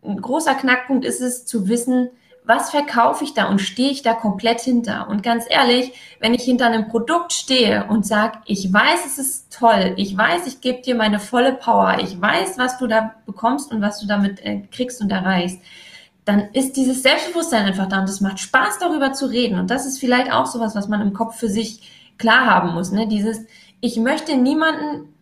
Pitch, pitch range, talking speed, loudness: 230 Hz, 210-255 Hz, 205 wpm, -18 LUFS